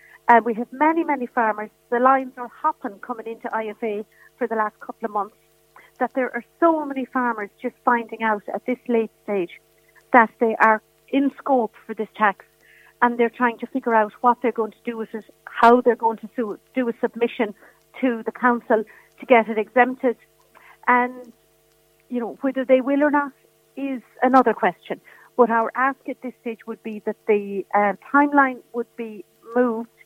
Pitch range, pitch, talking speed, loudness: 225-255 Hz, 240 Hz, 190 wpm, -21 LUFS